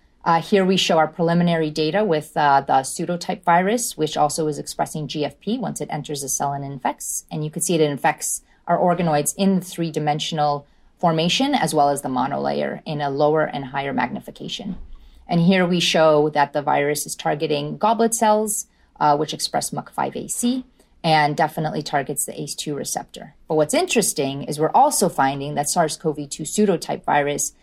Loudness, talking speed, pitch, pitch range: -21 LUFS, 170 wpm, 155 Hz, 145-175 Hz